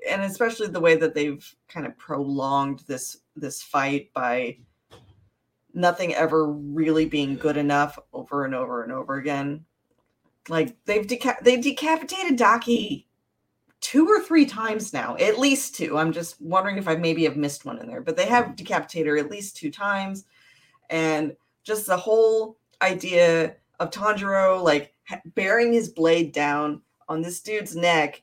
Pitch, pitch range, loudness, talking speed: 165 Hz, 145-215 Hz, -23 LUFS, 160 wpm